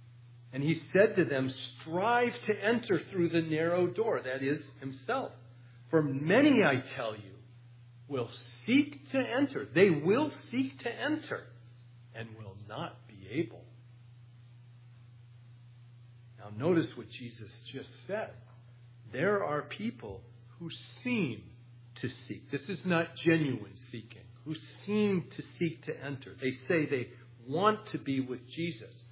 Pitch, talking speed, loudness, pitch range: 130 Hz, 135 wpm, -32 LUFS, 120-170 Hz